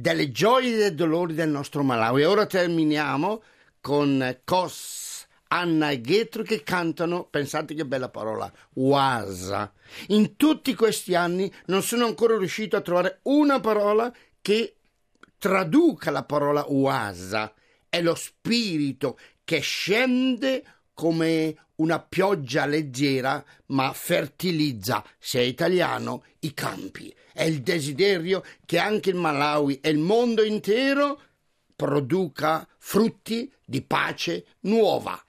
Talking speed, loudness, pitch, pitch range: 120 wpm, -24 LUFS, 170 Hz, 145-215 Hz